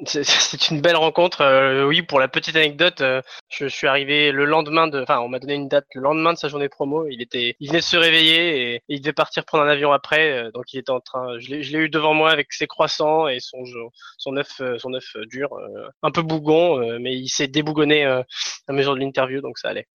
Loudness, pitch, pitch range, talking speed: -19 LUFS, 145 Hz, 130-160 Hz, 260 wpm